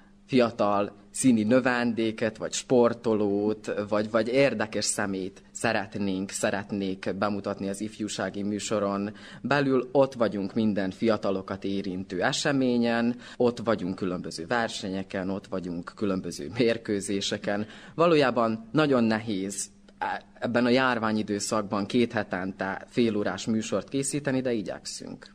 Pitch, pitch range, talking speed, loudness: 105 Hz, 100-120 Hz, 100 wpm, -27 LUFS